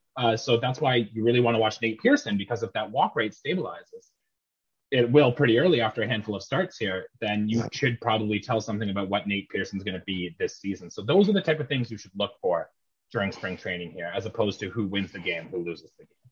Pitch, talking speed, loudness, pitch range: 110 Hz, 250 wpm, -26 LUFS, 100-125 Hz